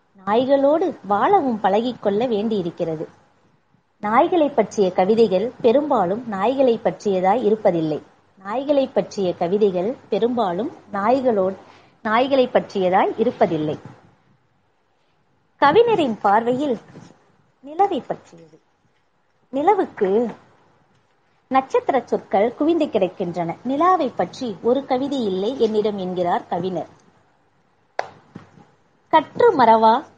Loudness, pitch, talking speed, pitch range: -20 LUFS, 225 Hz, 75 wpm, 195-270 Hz